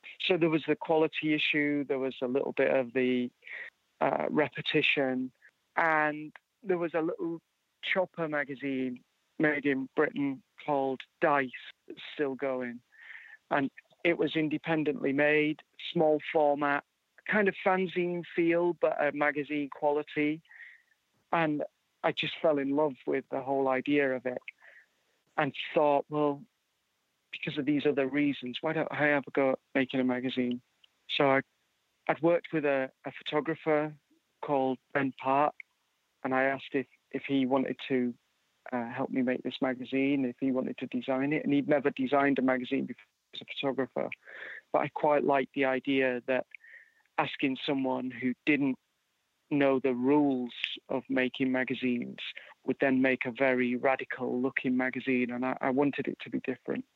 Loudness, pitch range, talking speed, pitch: -30 LUFS, 130-155 Hz, 155 wpm, 140 Hz